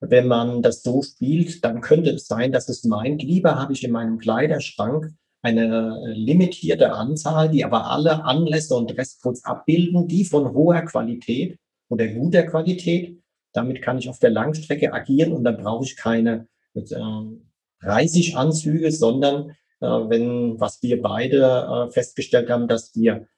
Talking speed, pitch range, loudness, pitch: 150 wpm, 115-155 Hz, -21 LUFS, 130 Hz